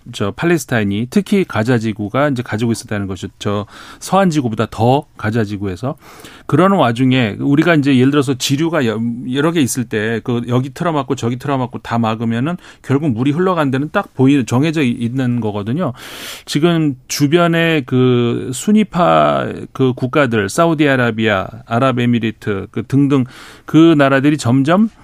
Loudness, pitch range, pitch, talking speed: -15 LUFS, 115-150 Hz, 130 Hz, 335 characters per minute